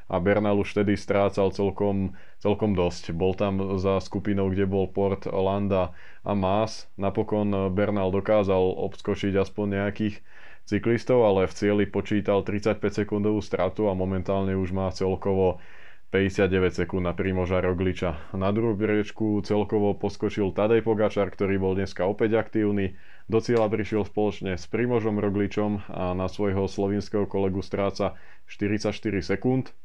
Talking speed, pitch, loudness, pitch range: 140 wpm, 100 Hz, -26 LUFS, 95-105 Hz